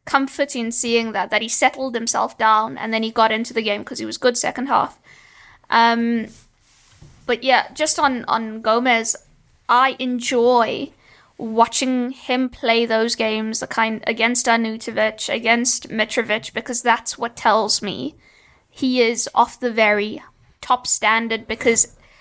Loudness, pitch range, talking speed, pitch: -19 LUFS, 225-250 Hz, 150 wpm, 230 Hz